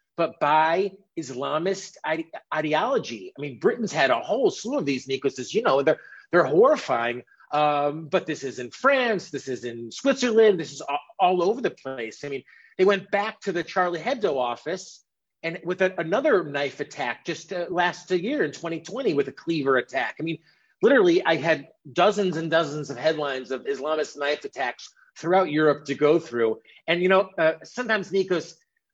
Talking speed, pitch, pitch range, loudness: 180 wpm, 160 Hz, 145-190 Hz, -24 LUFS